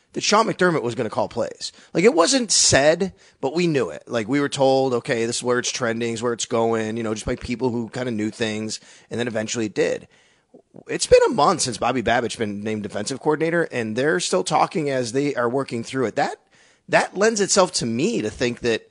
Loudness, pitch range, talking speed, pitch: -21 LUFS, 115-150 Hz, 240 wpm, 120 Hz